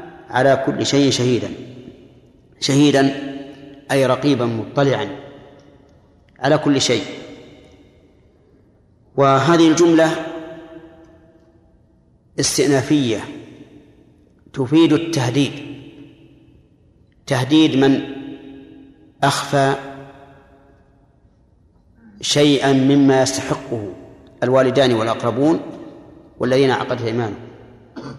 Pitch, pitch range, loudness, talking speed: 140 Hz, 130-145 Hz, -17 LUFS, 55 wpm